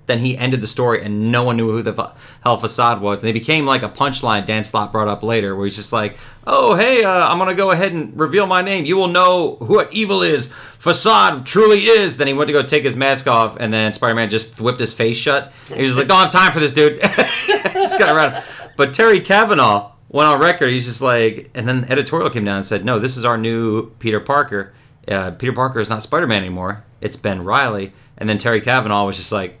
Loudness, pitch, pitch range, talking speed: -15 LUFS, 125 Hz, 110-150 Hz, 250 wpm